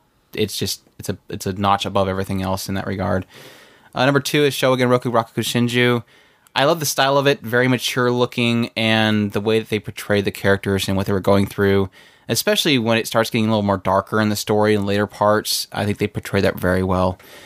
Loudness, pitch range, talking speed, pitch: -19 LUFS, 100-120 Hz, 225 wpm, 105 Hz